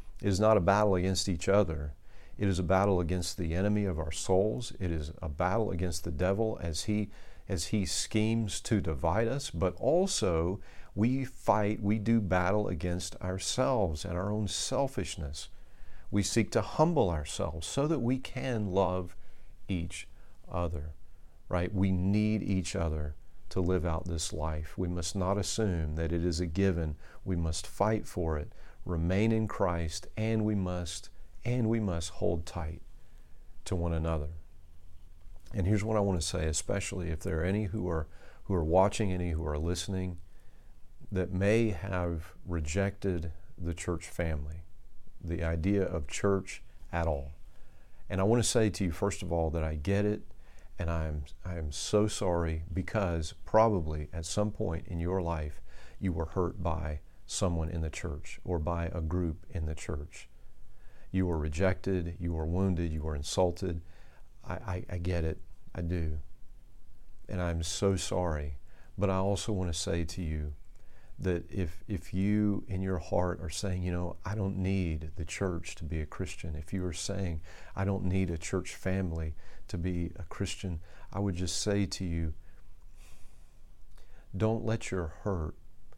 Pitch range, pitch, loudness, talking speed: 80-100 Hz, 90 Hz, -32 LUFS, 170 wpm